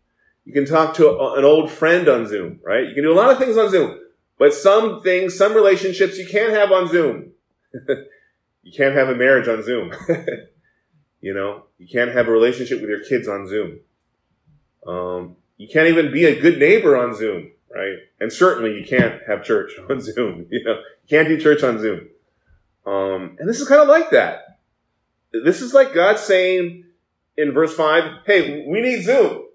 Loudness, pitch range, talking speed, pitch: -17 LUFS, 135-225 Hz, 195 wpm, 165 Hz